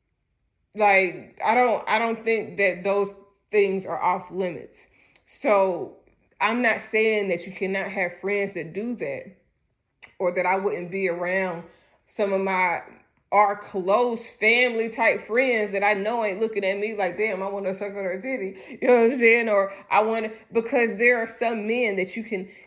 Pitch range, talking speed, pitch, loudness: 190-225 Hz, 185 wpm, 200 Hz, -23 LUFS